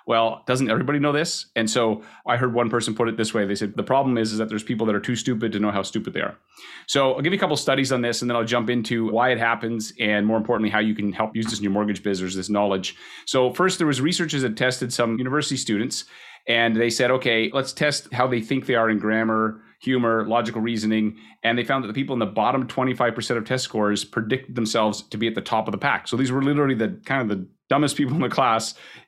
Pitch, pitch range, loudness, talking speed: 115 Hz, 110-130 Hz, -23 LUFS, 265 wpm